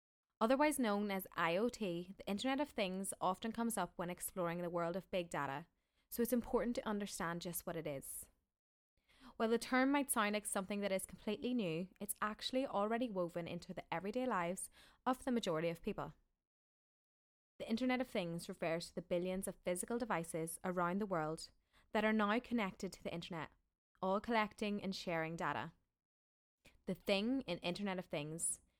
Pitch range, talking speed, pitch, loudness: 170-225 Hz, 175 wpm, 190 Hz, -40 LUFS